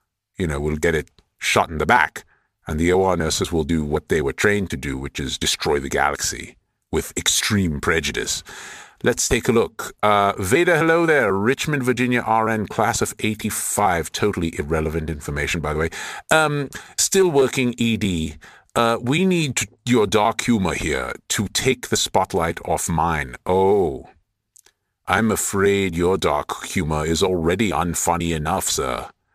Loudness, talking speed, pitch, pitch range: -20 LUFS, 155 wpm, 100 Hz, 85-120 Hz